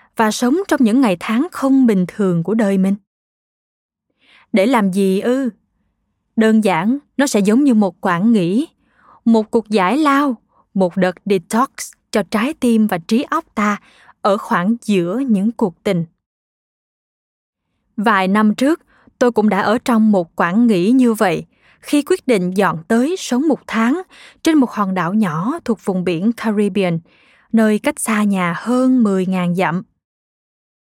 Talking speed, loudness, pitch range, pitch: 160 wpm, -16 LUFS, 195-250 Hz, 220 Hz